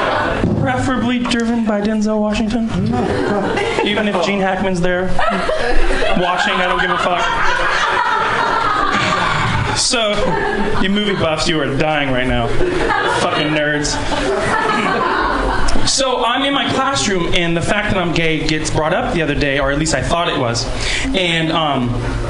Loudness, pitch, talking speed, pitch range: -16 LUFS, 180 Hz, 145 wpm, 155-230 Hz